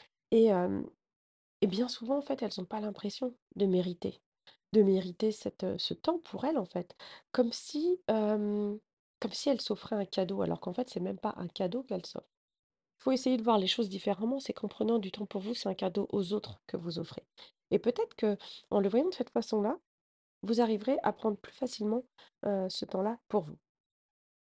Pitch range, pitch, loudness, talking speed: 200-245 Hz, 215 Hz, -33 LUFS, 205 wpm